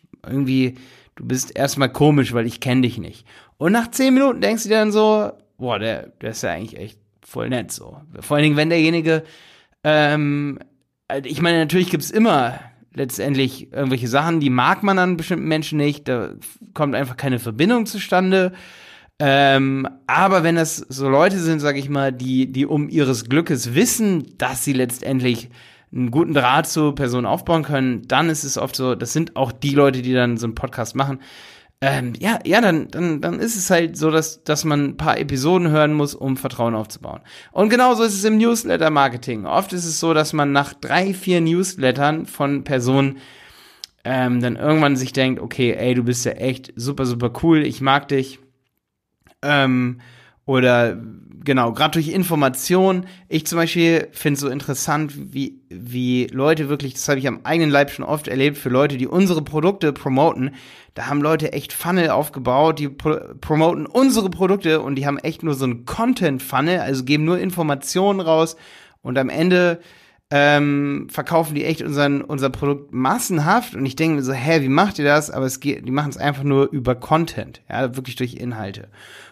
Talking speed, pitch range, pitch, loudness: 185 wpm, 130-165 Hz, 145 Hz, -19 LUFS